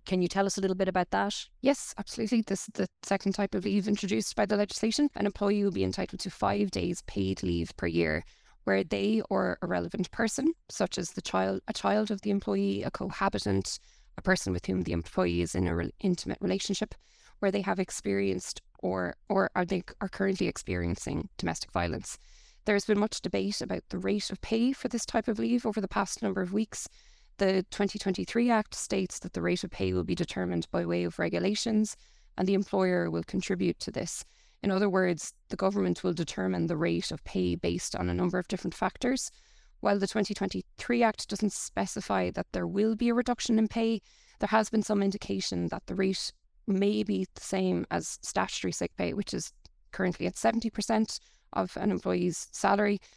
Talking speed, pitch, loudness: 200 wpm, 195 Hz, -30 LUFS